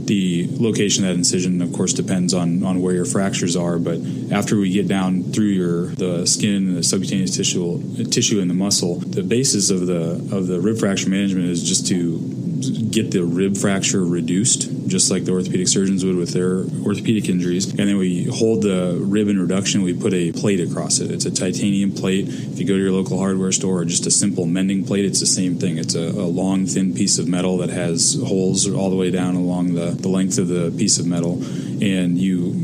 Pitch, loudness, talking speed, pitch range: 90 Hz, -19 LUFS, 220 wpm, 90-95 Hz